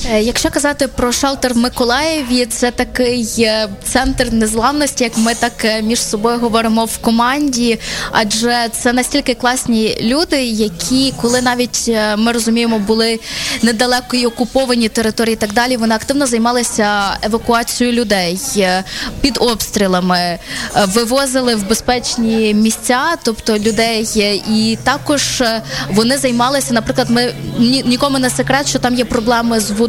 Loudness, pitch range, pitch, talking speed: -14 LUFS, 225-250 Hz, 235 Hz, 130 wpm